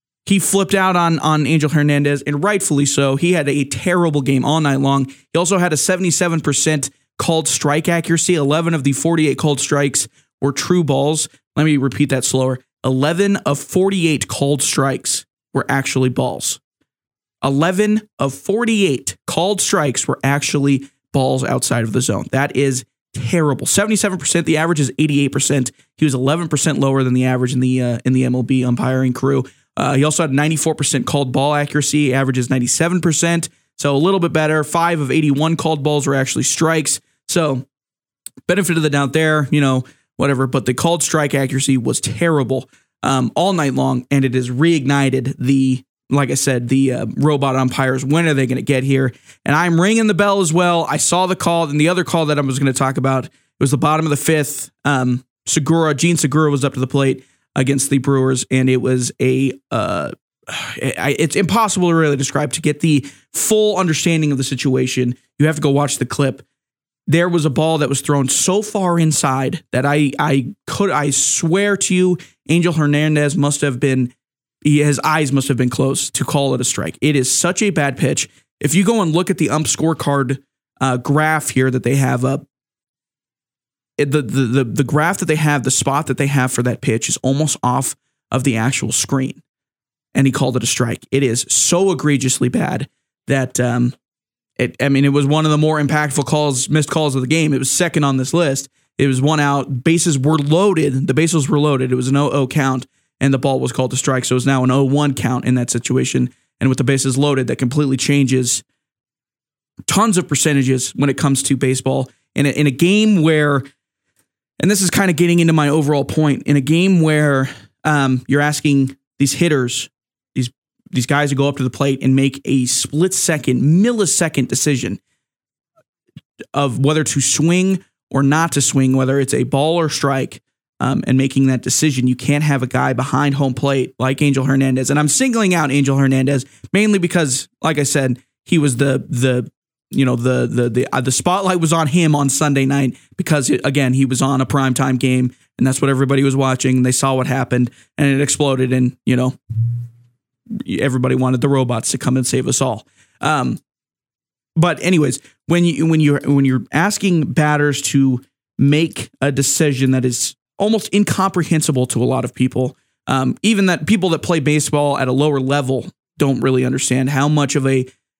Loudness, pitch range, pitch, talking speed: -16 LUFS, 130-155 Hz, 140 Hz, 195 wpm